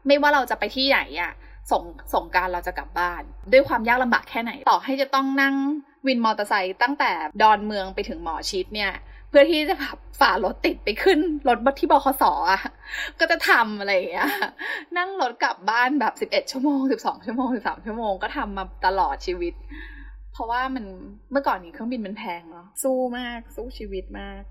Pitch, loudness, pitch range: 250 Hz, -23 LUFS, 200-280 Hz